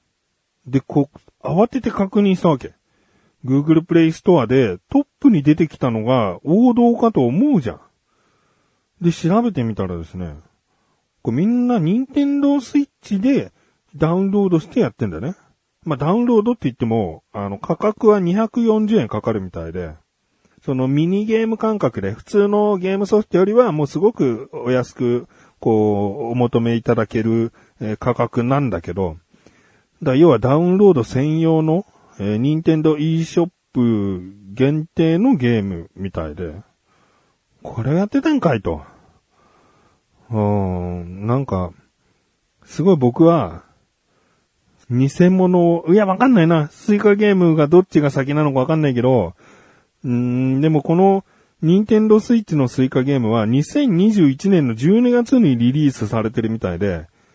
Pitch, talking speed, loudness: 150 Hz, 300 characters per minute, -17 LUFS